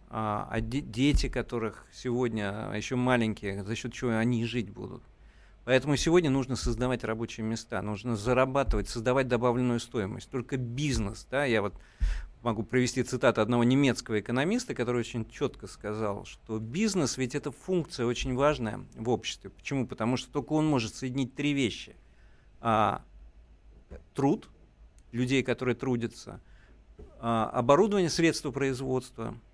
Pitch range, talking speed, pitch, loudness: 110-130 Hz, 130 wpm, 120 Hz, -30 LUFS